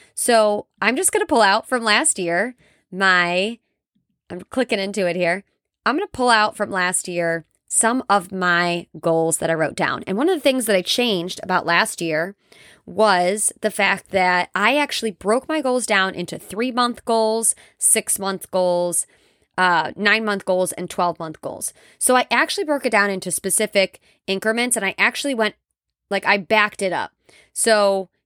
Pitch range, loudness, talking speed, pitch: 180-225 Hz, -19 LUFS, 185 wpm, 200 Hz